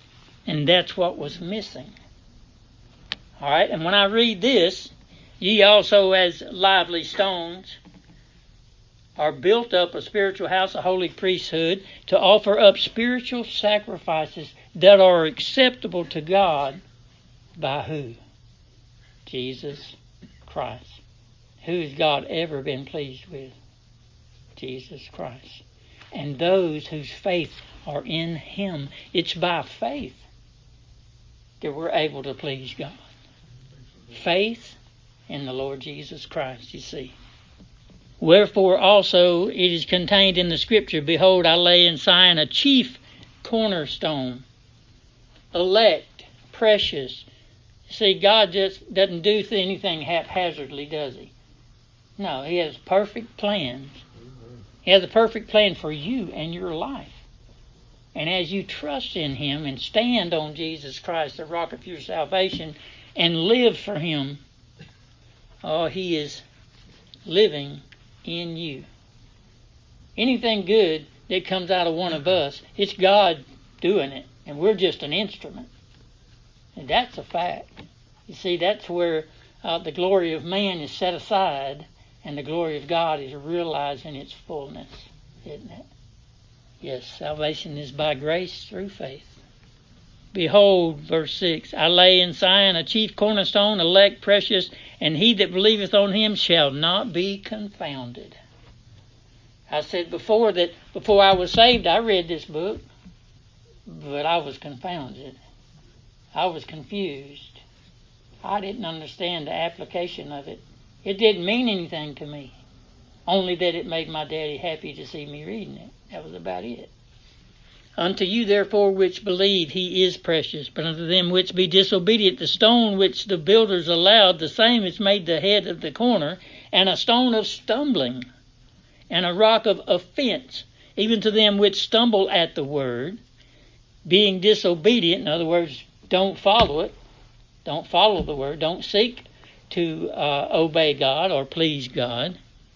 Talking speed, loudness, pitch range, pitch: 140 wpm, -21 LUFS, 135-195 Hz, 165 Hz